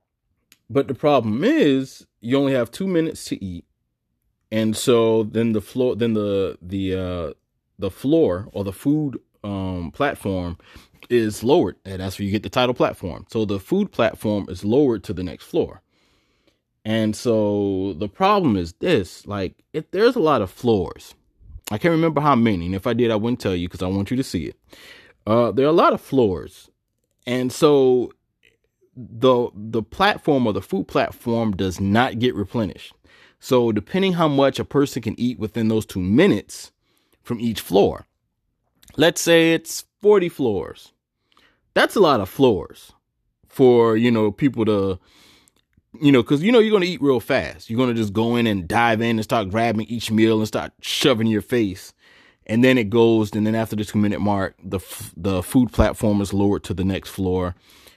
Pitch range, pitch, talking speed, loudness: 100-125 Hz, 110 Hz, 185 wpm, -20 LUFS